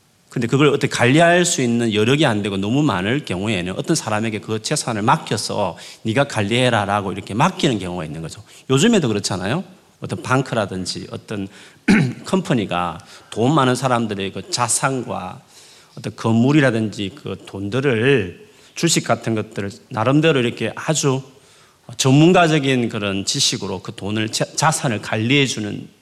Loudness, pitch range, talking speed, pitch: -19 LUFS, 105-140 Hz, 330 characters per minute, 120 Hz